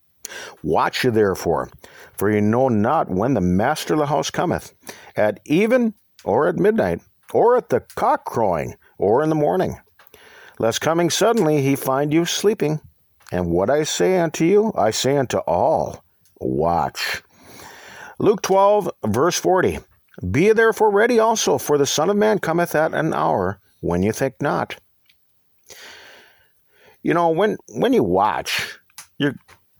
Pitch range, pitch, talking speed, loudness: 130-210 Hz, 155 Hz, 155 wpm, -19 LUFS